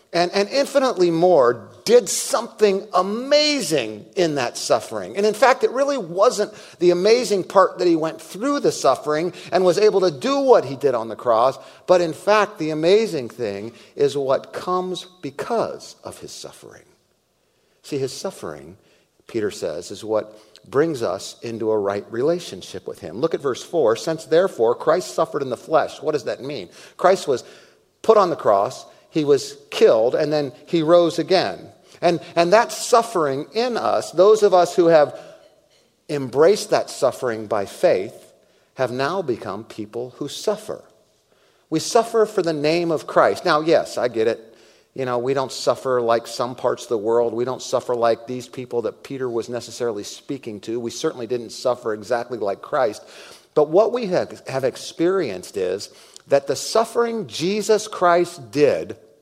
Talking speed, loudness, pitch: 170 wpm, -20 LUFS, 180 Hz